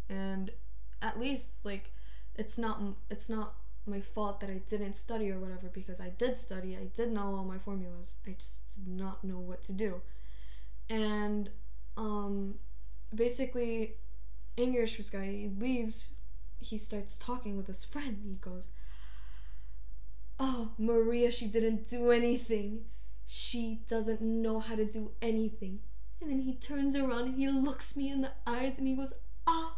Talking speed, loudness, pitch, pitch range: 155 wpm, -36 LUFS, 215 Hz, 190-235 Hz